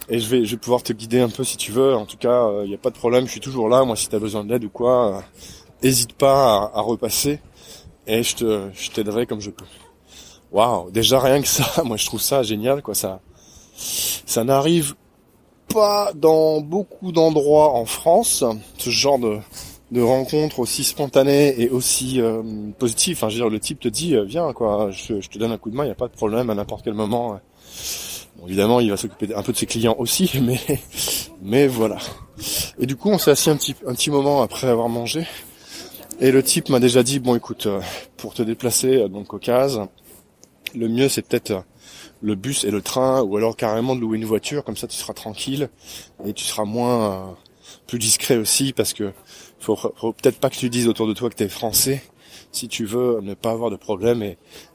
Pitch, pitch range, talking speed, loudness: 120 Hz, 110-135 Hz, 225 wpm, -20 LUFS